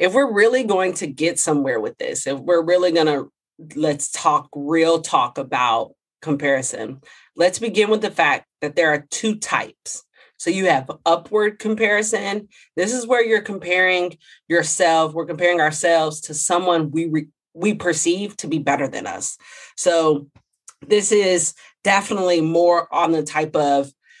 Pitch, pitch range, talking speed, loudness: 170 Hz, 155-200 Hz, 155 wpm, -19 LUFS